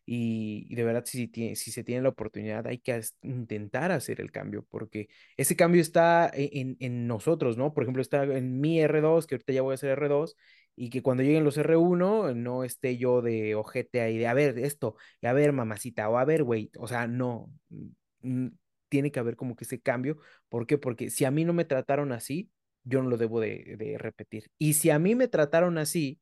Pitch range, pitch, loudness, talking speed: 120-150 Hz, 130 Hz, -28 LUFS, 225 wpm